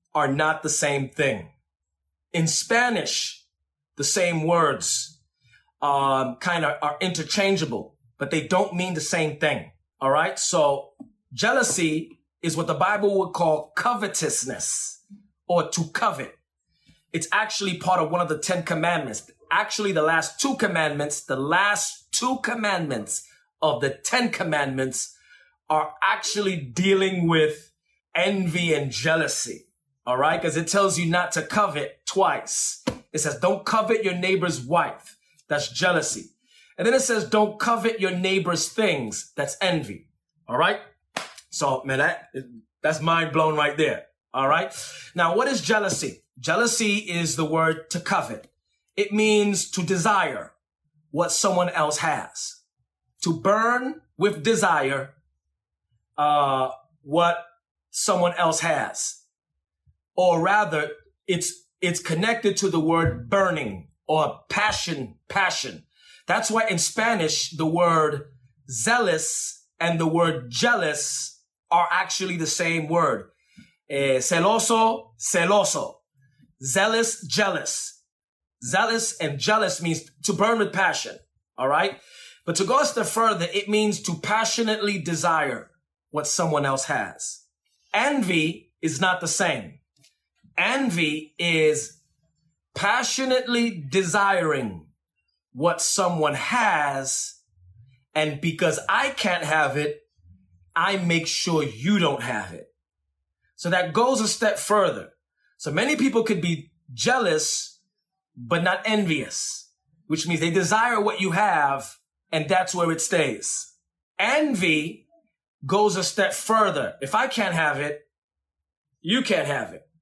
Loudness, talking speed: -23 LUFS, 130 wpm